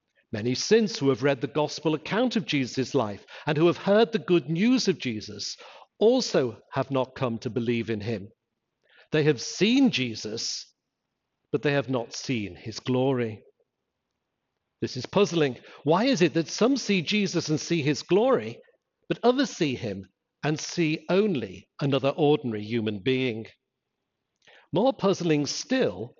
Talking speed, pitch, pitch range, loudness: 155 wpm, 150 Hz, 125-185 Hz, -26 LUFS